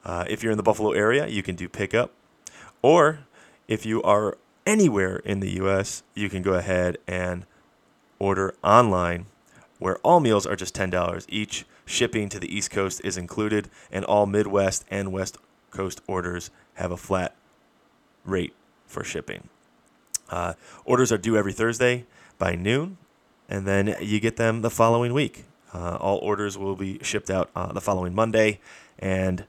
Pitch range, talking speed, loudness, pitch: 95-110 Hz, 165 wpm, -24 LUFS, 100 Hz